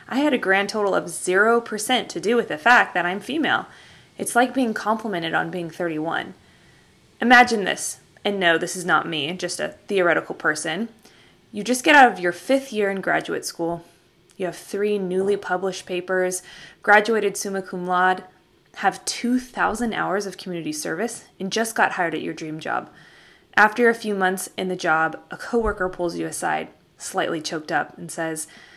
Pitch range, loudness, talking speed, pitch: 175-225 Hz, -22 LUFS, 180 wpm, 190 Hz